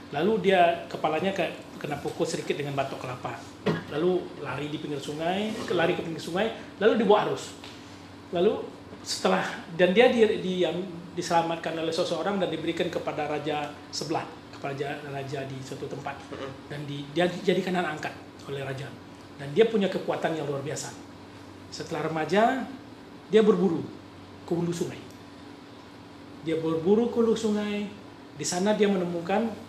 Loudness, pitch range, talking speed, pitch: -27 LUFS, 145-190 Hz, 150 wpm, 165 Hz